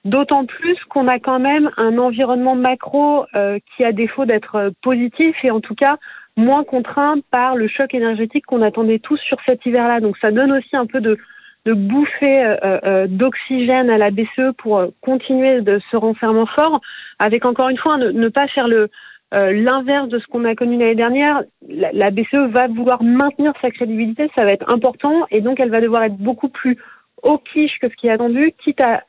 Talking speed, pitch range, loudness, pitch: 205 wpm, 225-275 Hz, -16 LUFS, 250 Hz